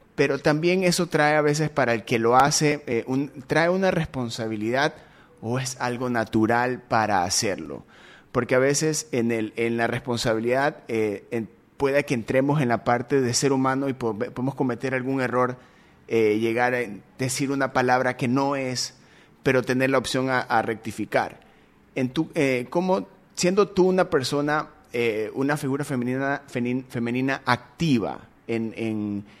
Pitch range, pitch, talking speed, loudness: 120-140 Hz, 130 Hz, 160 wpm, -24 LUFS